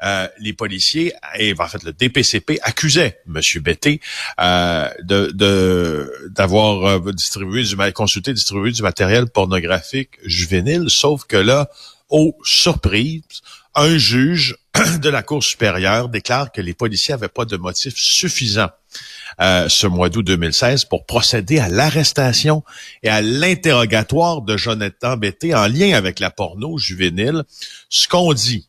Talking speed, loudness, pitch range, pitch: 140 wpm, -16 LUFS, 100-145 Hz, 110 Hz